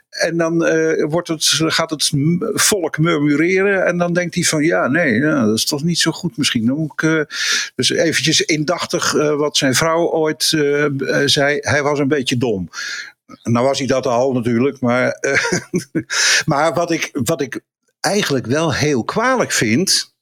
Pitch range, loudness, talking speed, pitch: 145-170 Hz, -16 LUFS, 180 wpm, 155 Hz